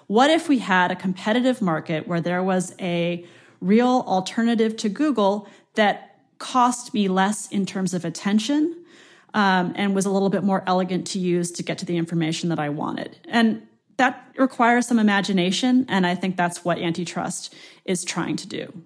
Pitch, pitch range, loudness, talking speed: 195 Hz, 175-230 Hz, -22 LUFS, 180 wpm